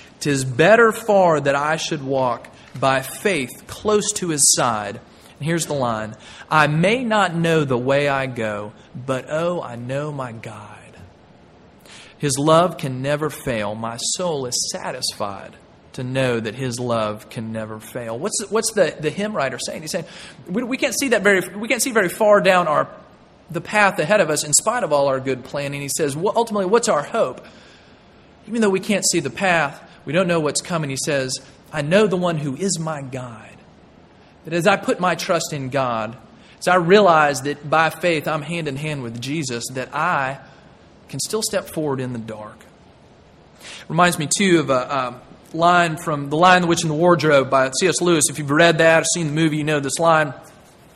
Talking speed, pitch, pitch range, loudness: 200 wpm, 155 Hz, 135-180 Hz, -19 LUFS